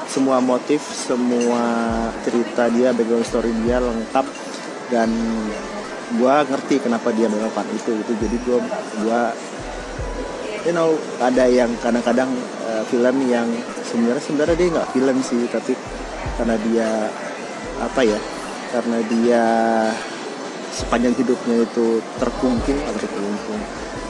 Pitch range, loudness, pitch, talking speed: 115-125 Hz, -20 LUFS, 120 Hz, 115 wpm